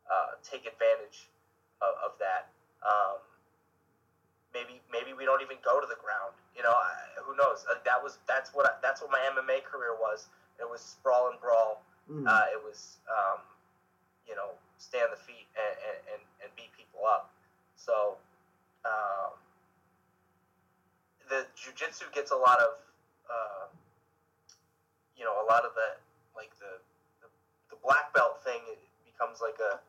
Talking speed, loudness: 160 wpm, -31 LUFS